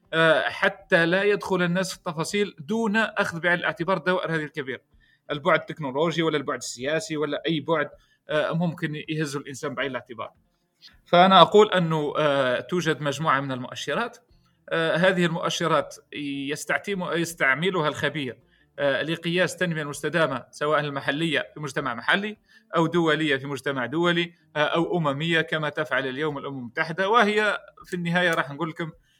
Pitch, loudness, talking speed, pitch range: 160 Hz, -24 LUFS, 130 wpm, 145-175 Hz